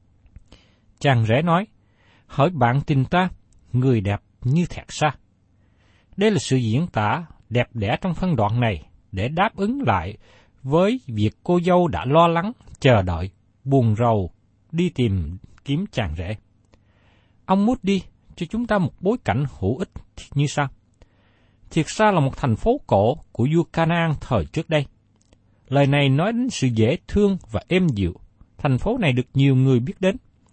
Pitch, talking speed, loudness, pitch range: 125 Hz, 170 wpm, -21 LUFS, 105-165 Hz